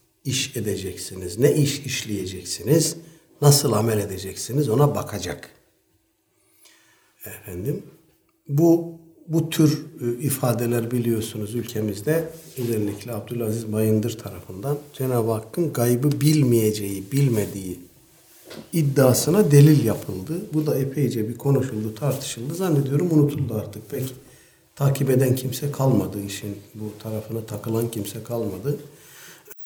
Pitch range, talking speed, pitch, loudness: 110-145 Hz, 100 wpm, 125 Hz, -23 LUFS